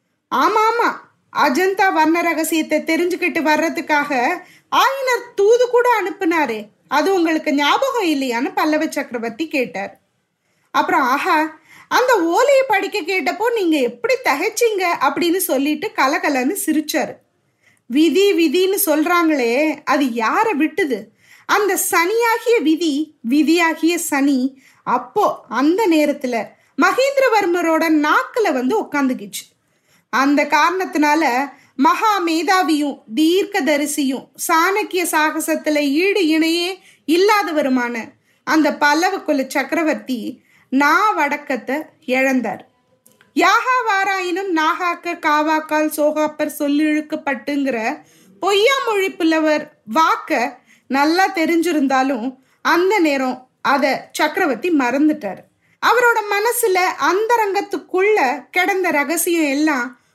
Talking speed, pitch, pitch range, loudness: 85 wpm, 320 Hz, 290-380 Hz, -17 LUFS